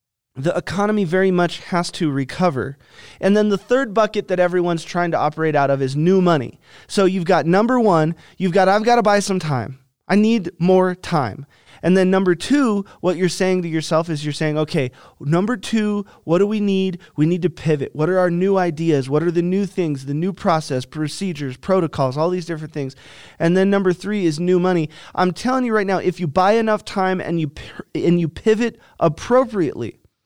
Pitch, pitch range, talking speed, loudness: 180 Hz, 155-195 Hz, 210 wpm, -19 LUFS